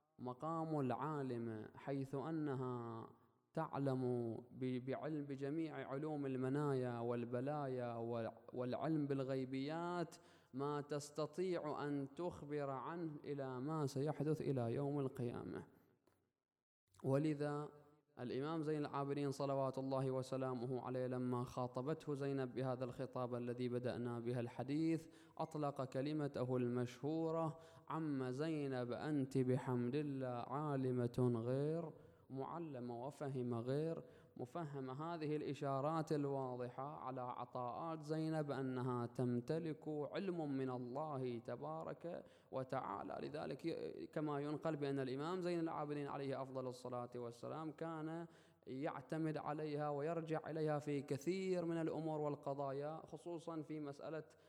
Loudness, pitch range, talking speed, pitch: -44 LUFS, 125-155 Hz, 100 wpm, 140 Hz